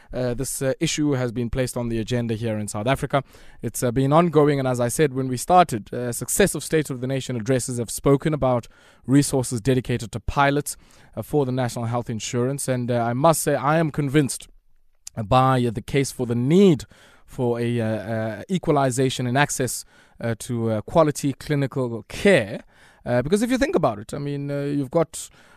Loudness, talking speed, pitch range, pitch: -22 LUFS, 200 wpm, 120-145 Hz, 130 Hz